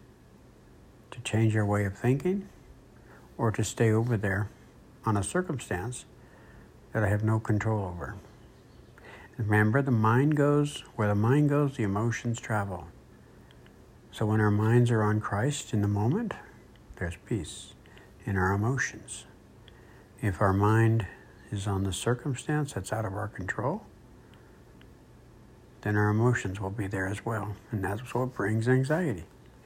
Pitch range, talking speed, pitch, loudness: 100-120 Hz, 145 wpm, 110 Hz, -29 LUFS